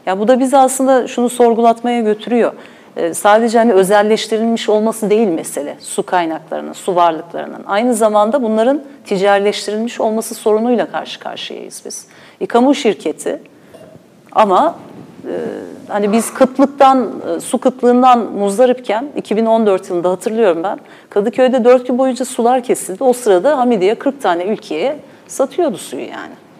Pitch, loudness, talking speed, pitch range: 230 Hz, -14 LUFS, 130 wpm, 210-255 Hz